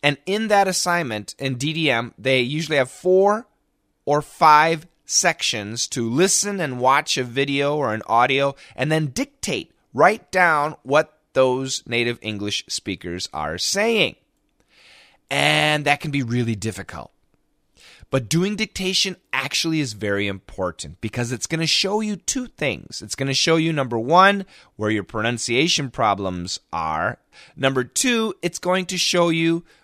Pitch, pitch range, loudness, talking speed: 145 Hz, 120-175 Hz, -20 LUFS, 145 wpm